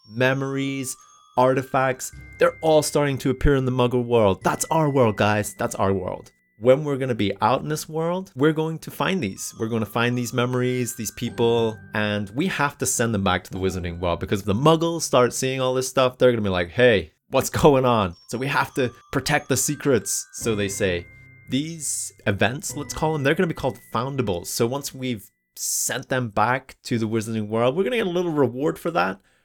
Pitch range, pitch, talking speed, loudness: 105-140 Hz, 125 Hz, 220 wpm, -23 LUFS